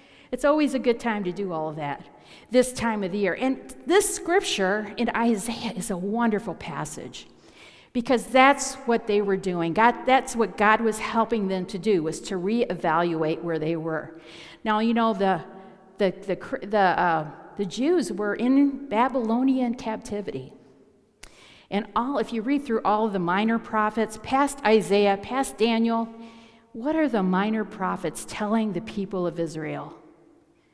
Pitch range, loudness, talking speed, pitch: 190-235 Hz, -24 LUFS, 165 wpm, 215 Hz